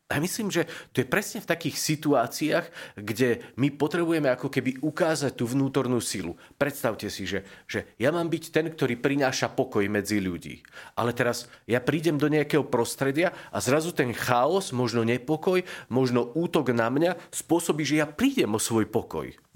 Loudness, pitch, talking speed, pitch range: -26 LUFS, 140 Hz, 170 wpm, 120-160 Hz